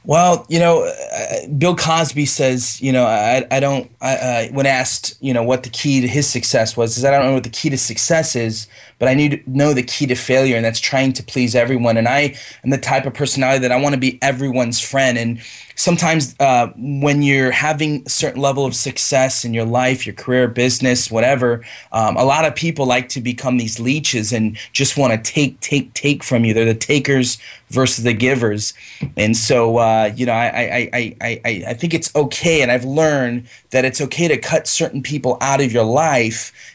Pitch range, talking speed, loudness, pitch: 120-145 Hz, 220 wpm, -16 LUFS, 130 Hz